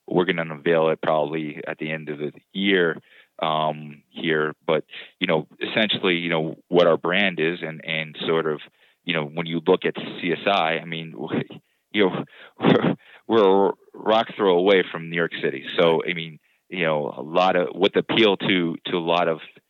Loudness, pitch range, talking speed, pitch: -22 LUFS, 80-85 Hz, 195 wpm, 80 Hz